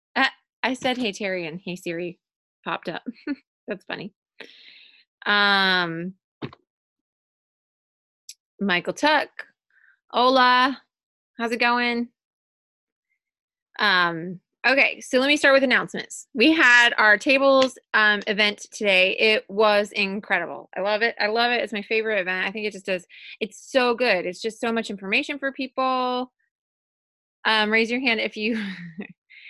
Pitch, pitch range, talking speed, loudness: 220 Hz, 195-250 Hz, 135 wpm, -21 LUFS